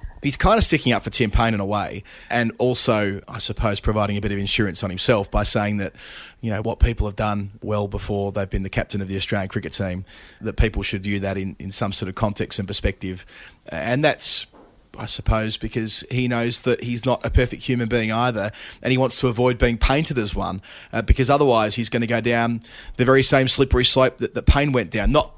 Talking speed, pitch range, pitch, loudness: 225 wpm, 100-120 Hz, 110 Hz, -20 LUFS